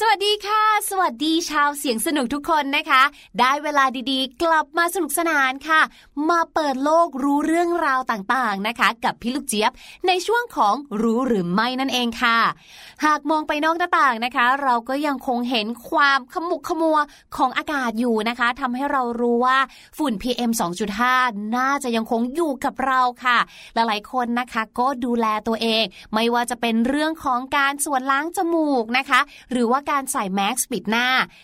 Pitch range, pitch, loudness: 240-305 Hz, 265 Hz, -20 LUFS